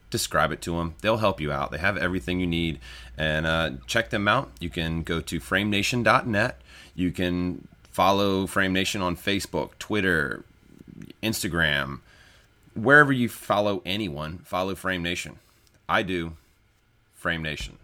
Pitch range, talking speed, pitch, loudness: 80-100 Hz, 145 wpm, 90 Hz, -25 LUFS